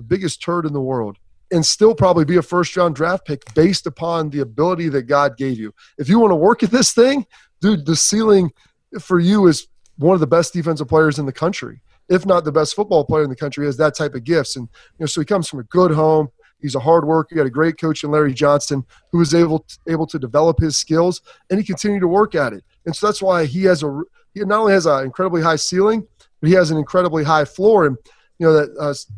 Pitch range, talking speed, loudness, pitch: 145-180 Hz, 255 wpm, -17 LUFS, 160 Hz